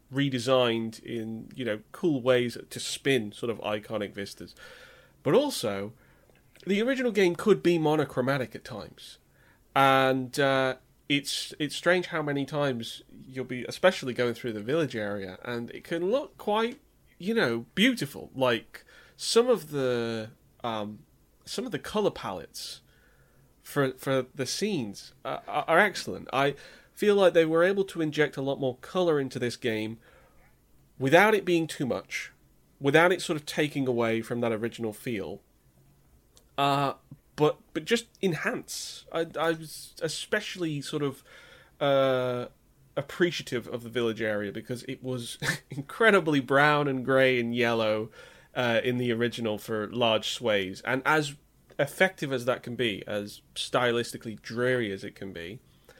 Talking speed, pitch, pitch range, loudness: 150 wpm, 135 Hz, 120-155 Hz, -28 LUFS